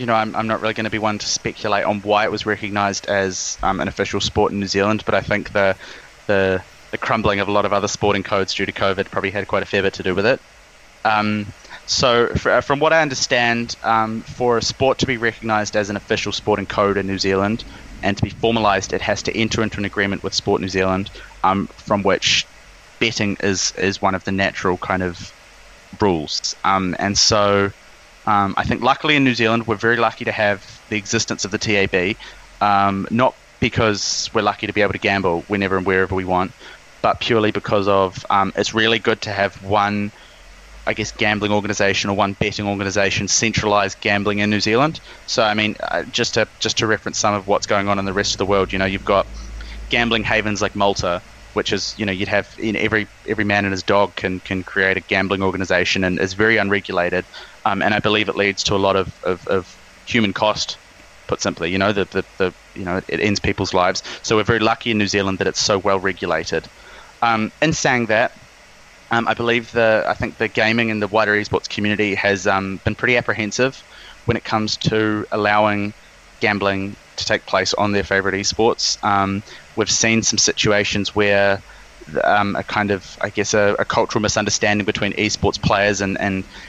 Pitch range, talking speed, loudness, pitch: 100-110 Hz, 215 wpm, -19 LUFS, 105 Hz